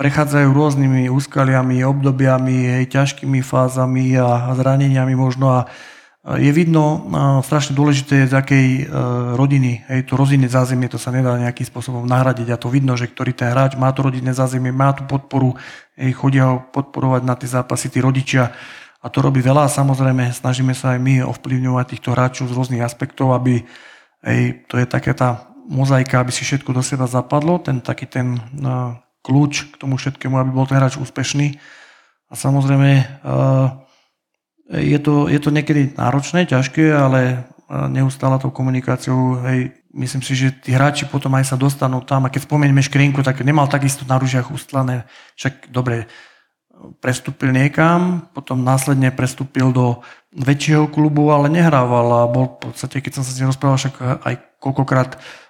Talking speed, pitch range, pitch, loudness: 170 wpm, 125-140 Hz, 130 Hz, -17 LUFS